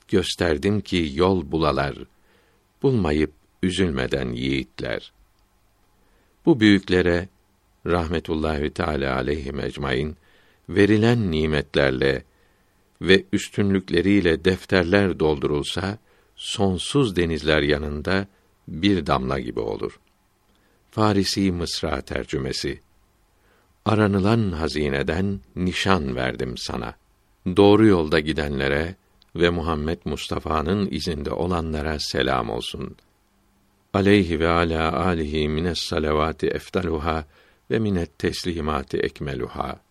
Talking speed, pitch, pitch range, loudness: 85 wpm, 90 Hz, 75-95 Hz, -22 LUFS